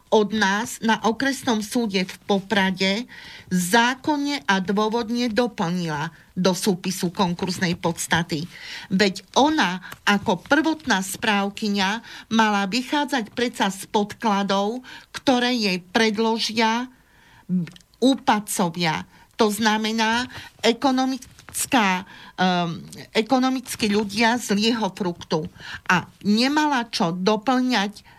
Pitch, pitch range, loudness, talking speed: 215 Hz, 190-240 Hz, -22 LUFS, 85 wpm